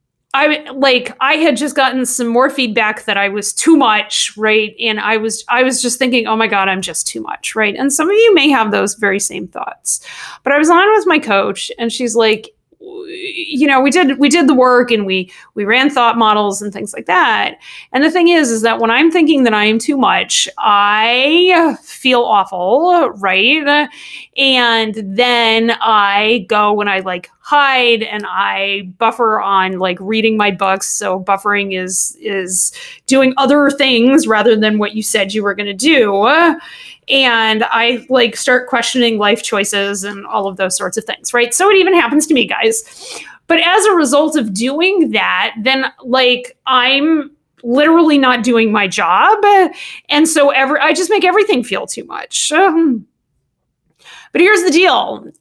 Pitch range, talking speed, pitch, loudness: 215-300 Hz, 185 wpm, 245 Hz, -12 LUFS